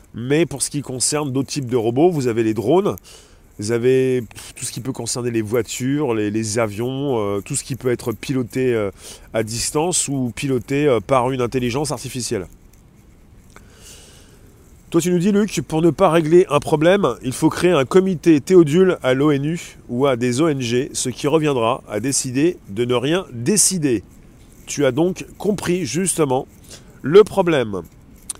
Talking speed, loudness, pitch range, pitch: 170 wpm, -19 LUFS, 120-160 Hz, 135 Hz